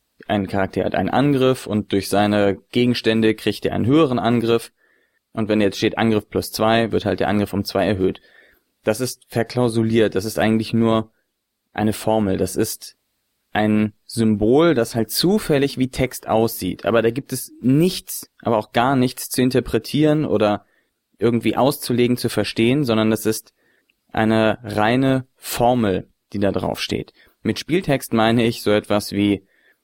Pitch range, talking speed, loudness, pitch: 105-125 Hz, 160 wpm, -20 LUFS, 110 Hz